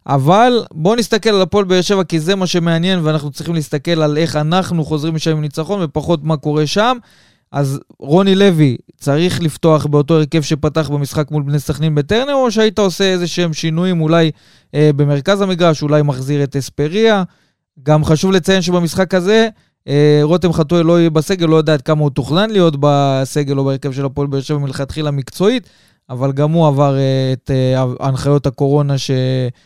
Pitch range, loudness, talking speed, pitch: 145-180 Hz, -14 LUFS, 180 wpm, 155 Hz